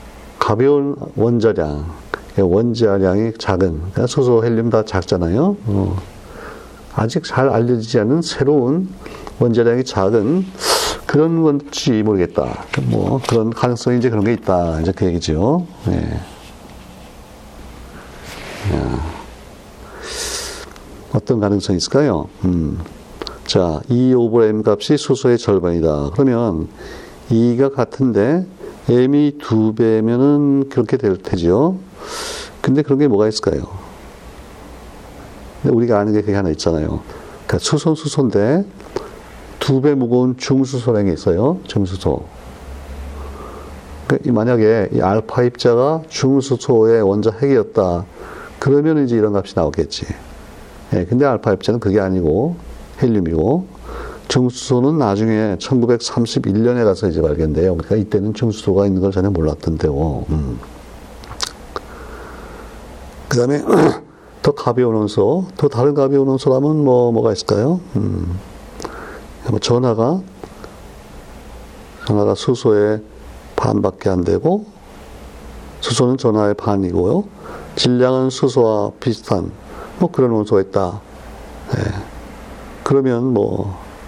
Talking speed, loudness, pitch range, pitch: 240 characters per minute, -16 LUFS, 95-135 Hz, 115 Hz